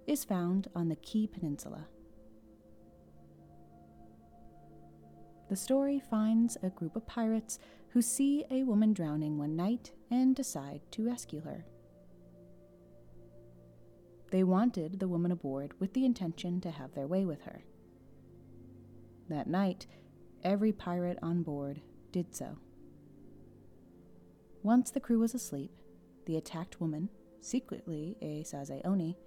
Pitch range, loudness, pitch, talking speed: 130-215 Hz, -34 LUFS, 170 Hz, 120 wpm